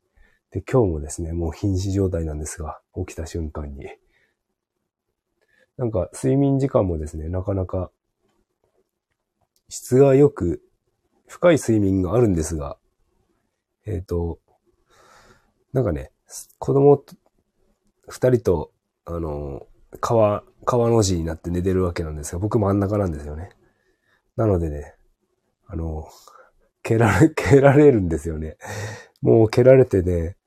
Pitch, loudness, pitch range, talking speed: 95 Hz, -20 LUFS, 80-115 Hz, 235 characters per minute